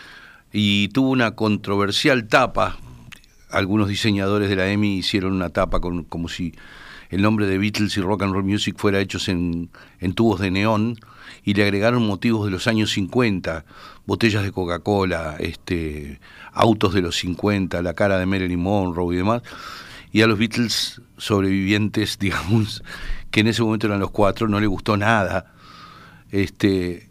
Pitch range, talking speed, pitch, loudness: 95-110 Hz, 160 wpm, 100 Hz, -21 LUFS